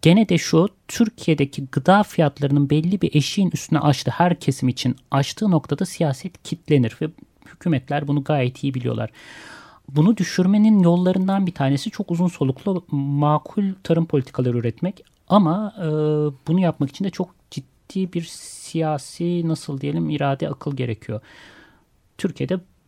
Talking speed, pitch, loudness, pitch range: 135 wpm, 155 Hz, -21 LUFS, 140-180 Hz